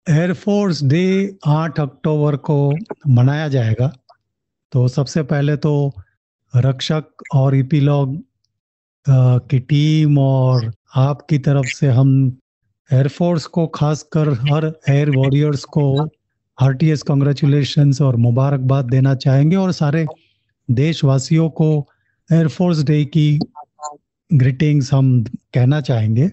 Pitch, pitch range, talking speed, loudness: 145 Hz, 130-155 Hz, 105 wpm, -16 LUFS